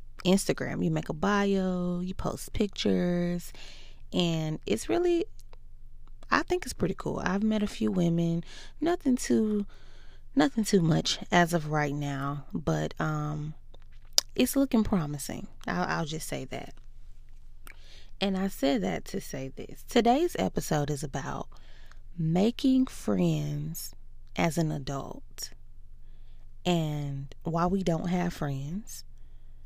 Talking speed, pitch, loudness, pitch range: 125 wpm, 165 Hz, -29 LUFS, 135-195 Hz